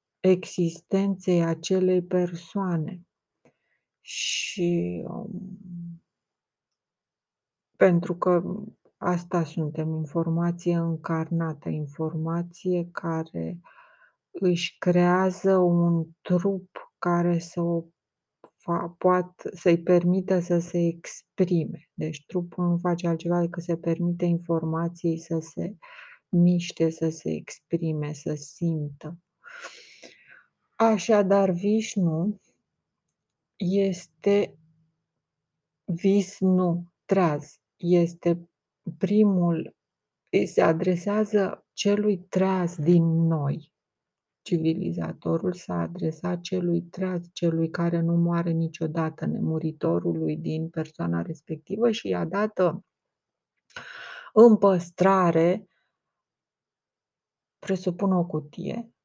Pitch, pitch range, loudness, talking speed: 175 Hz, 165-185 Hz, -26 LUFS, 80 wpm